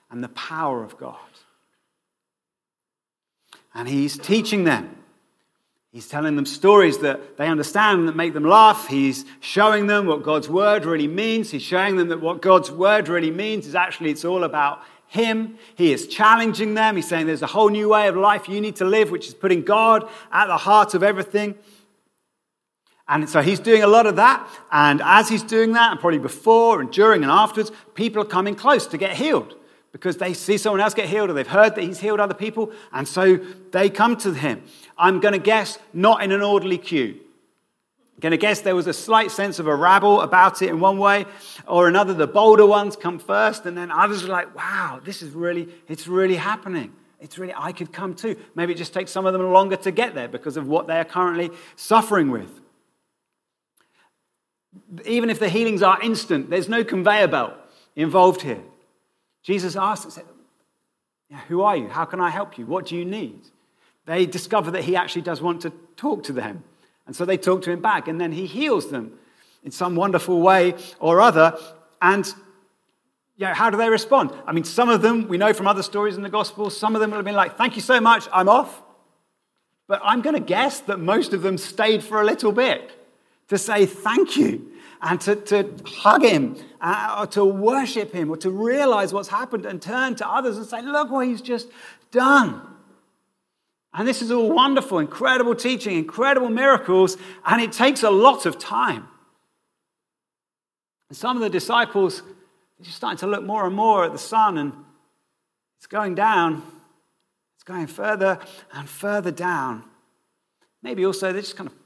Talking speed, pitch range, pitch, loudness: 200 wpm, 175-220 Hz, 195 Hz, -19 LUFS